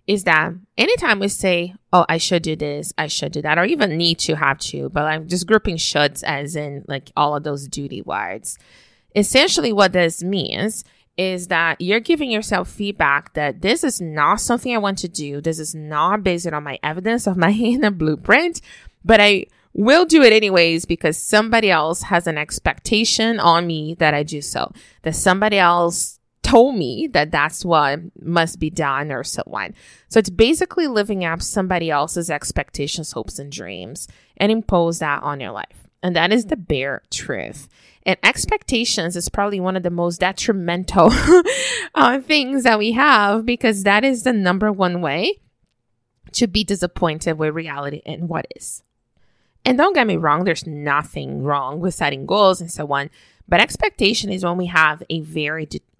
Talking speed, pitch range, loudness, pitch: 180 wpm, 155-210 Hz, -18 LUFS, 175 Hz